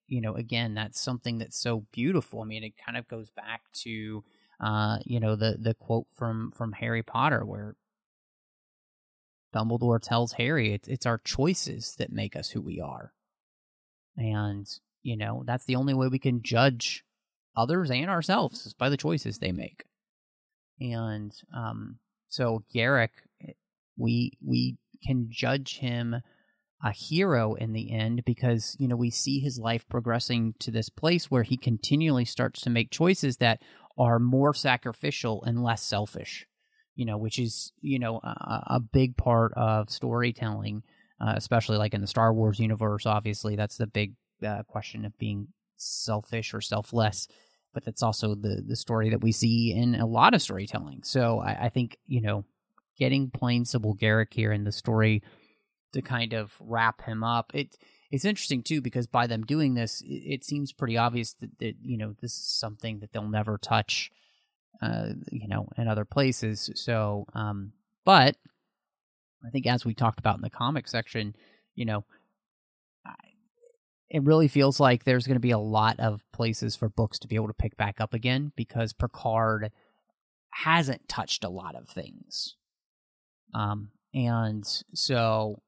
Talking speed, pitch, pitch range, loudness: 170 wpm, 115 Hz, 110-130 Hz, -28 LUFS